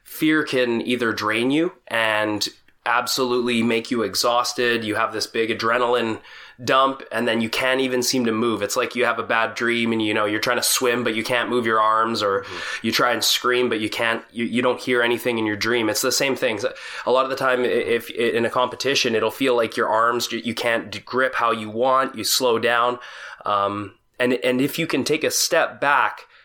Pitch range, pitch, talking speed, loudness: 115-125 Hz, 120 Hz, 225 wpm, -21 LUFS